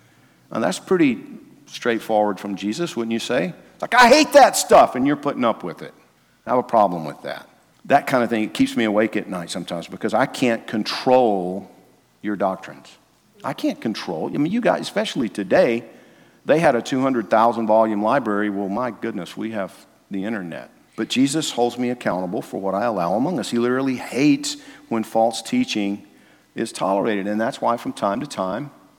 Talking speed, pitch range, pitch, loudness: 190 wpm, 105-140 Hz, 115 Hz, -20 LUFS